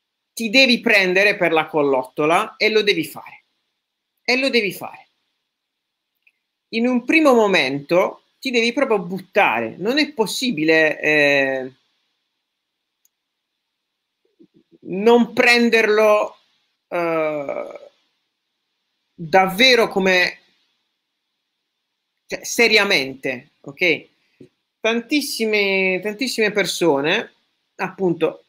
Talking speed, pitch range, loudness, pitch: 80 wpm, 175-240 Hz, -17 LUFS, 210 Hz